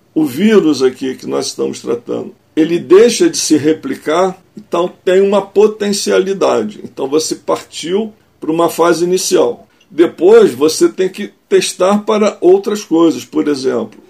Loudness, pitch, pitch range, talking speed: -13 LUFS, 190 Hz, 165-225 Hz, 140 wpm